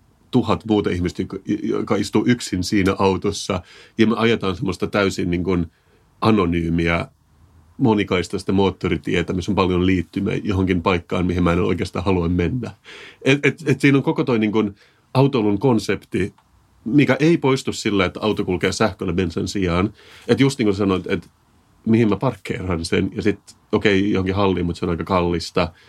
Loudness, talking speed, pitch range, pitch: -20 LUFS, 165 wpm, 90-110 Hz, 100 Hz